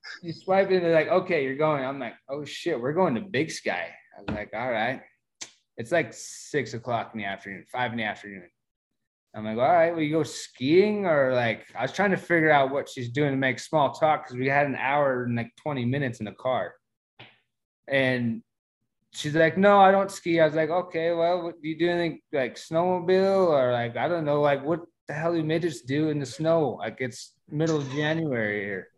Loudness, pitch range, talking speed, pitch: -25 LUFS, 130-170 Hz, 220 wpm, 150 Hz